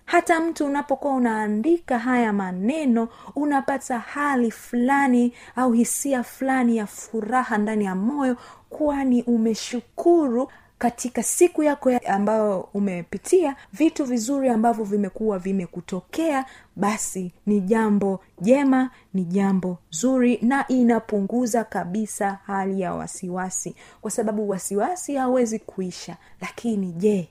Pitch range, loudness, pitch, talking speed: 200-265 Hz, -23 LUFS, 235 Hz, 110 wpm